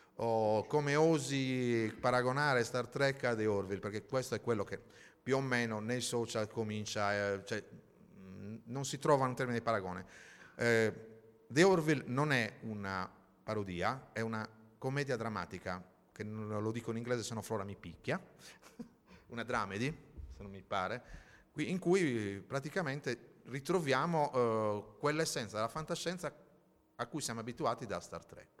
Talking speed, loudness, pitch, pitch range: 155 wpm, -36 LUFS, 115 Hz, 105-135 Hz